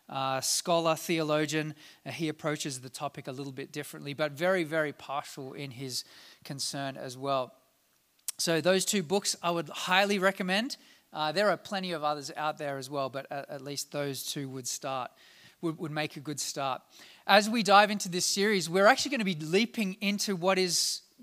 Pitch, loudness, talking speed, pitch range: 155 Hz, -30 LUFS, 190 wpm, 140-195 Hz